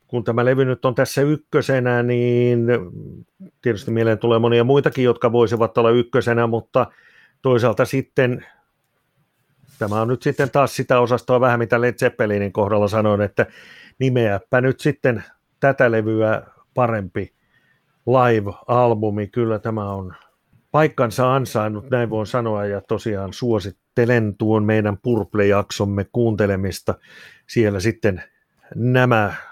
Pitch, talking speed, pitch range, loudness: 120 Hz, 120 wpm, 110-125 Hz, -19 LUFS